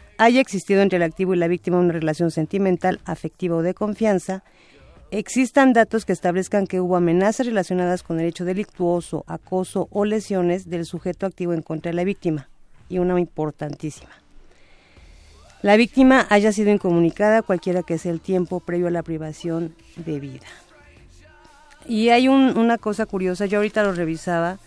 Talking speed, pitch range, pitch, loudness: 165 wpm, 170-210 Hz, 180 Hz, -21 LUFS